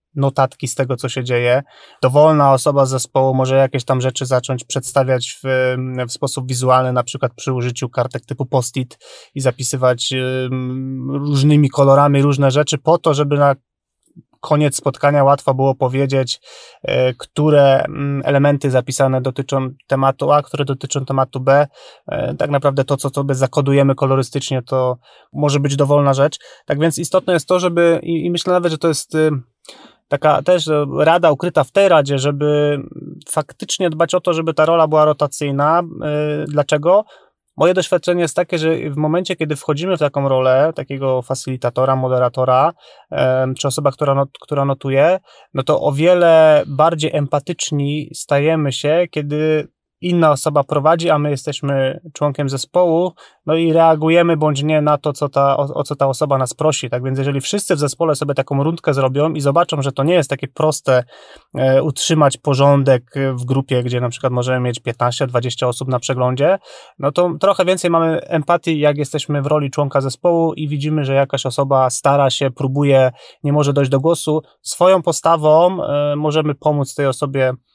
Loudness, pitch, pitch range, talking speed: -16 LUFS, 140 Hz, 135-155 Hz, 165 wpm